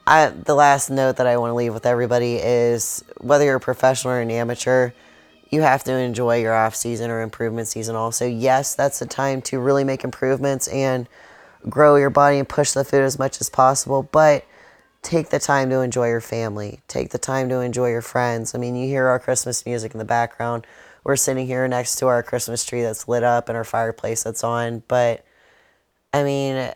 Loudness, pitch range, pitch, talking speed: -20 LUFS, 115-135 Hz, 125 Hz, 210 wpm